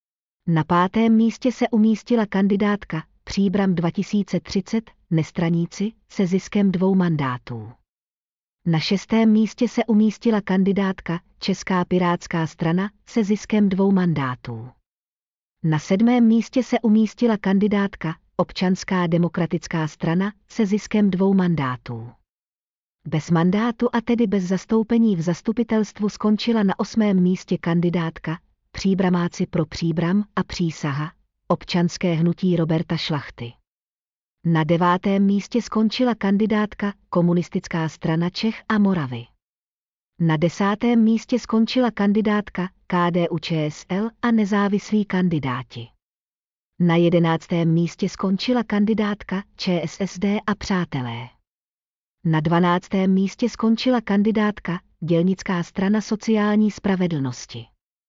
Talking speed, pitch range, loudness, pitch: 100 wpm, 165-210 Hz, -21 LUFS, 185 Hz